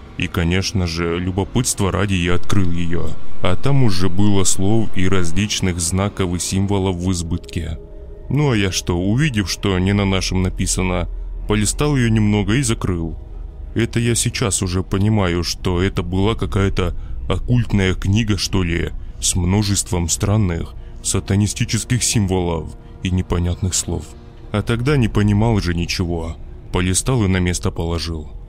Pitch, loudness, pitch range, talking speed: 95 Hz, -19 LUFS, 85-105 Hz, 140 wpm